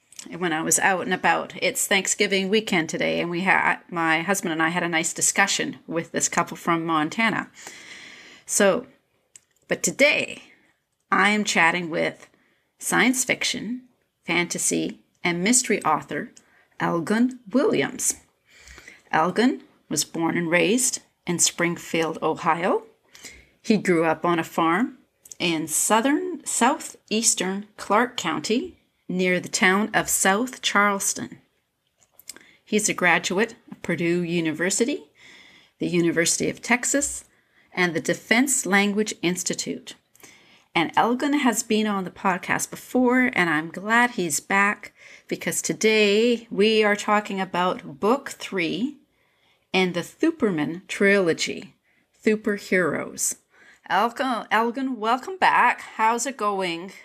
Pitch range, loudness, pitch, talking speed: 175-235 Hz, -22 LUFS, 200 Hz, 120 wpm